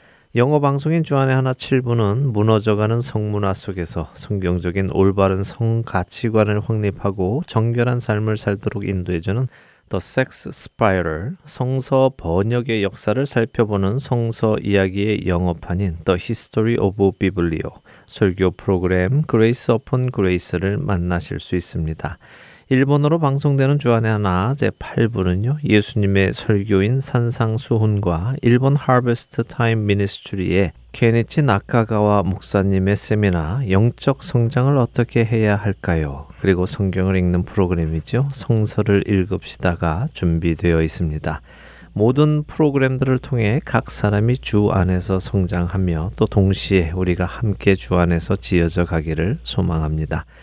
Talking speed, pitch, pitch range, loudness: 330 characters per minute, 105 Hz, 95-120 Hz, -19 LUFS